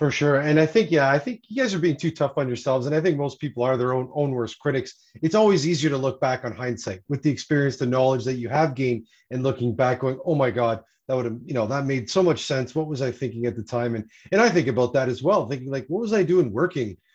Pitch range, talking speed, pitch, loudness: 125-155 Hz, 290 wpm, 135 Hz, -23 LUFS